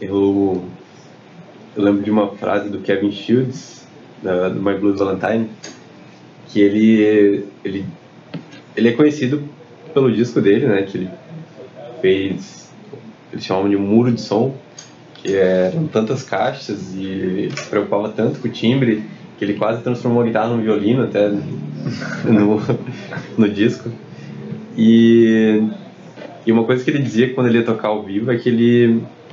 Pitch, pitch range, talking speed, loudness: 110 Hz, 100-120 Hz, 150 wpm, -17 LUFS